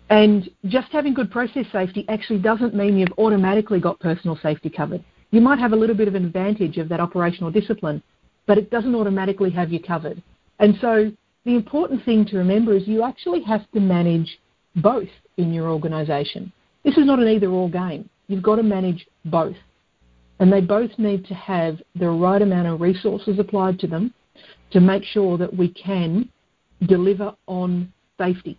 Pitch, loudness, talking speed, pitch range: 195 Hz, -20 LUFS, 185 wpm, 175-215 Hz